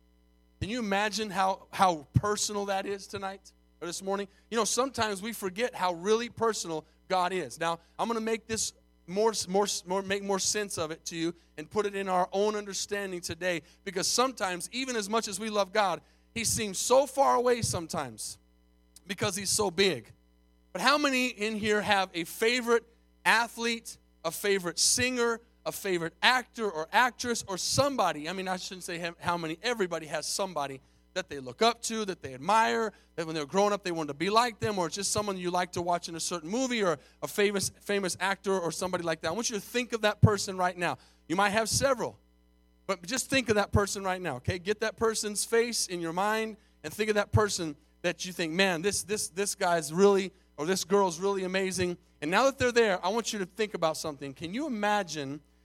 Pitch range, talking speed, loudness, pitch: 170-215 Hz, 215 wpm, -29 LUFS, 195 Hz